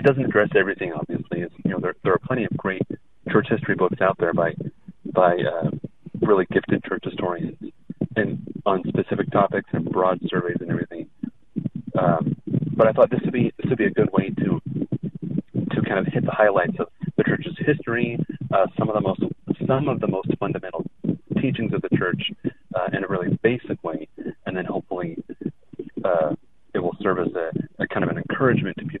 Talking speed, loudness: 195 wpm, -23 LUFS